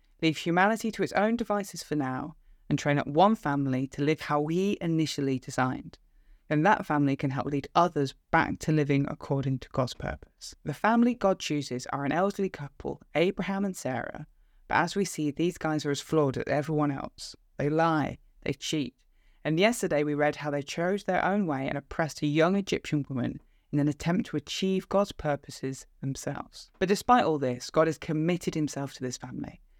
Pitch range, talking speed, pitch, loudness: 140-180 Hz, 190 wpm, 150 Hz, -29 LUFS